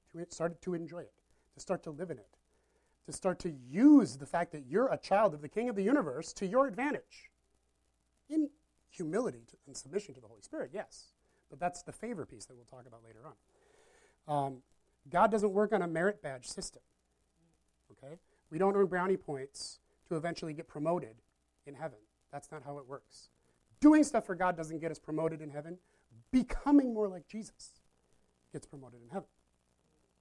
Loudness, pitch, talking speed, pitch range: -33 LUFS, 165 Hz, 185 wpm, 135-205 Hz